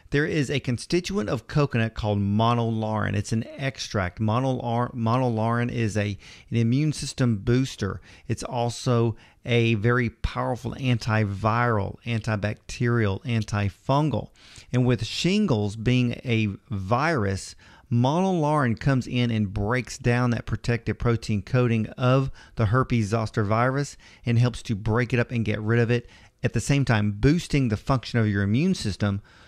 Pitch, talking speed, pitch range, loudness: 115 Hz, 140 wpm, 110-125 Hz, -25 LUFS